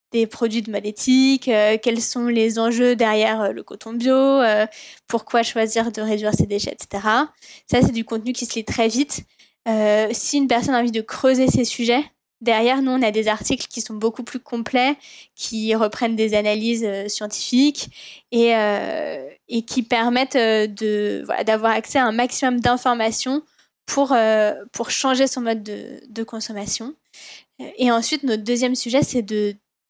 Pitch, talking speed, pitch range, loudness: 230 Hz, 180 wpm, 220-255 Hz, -20 LUFS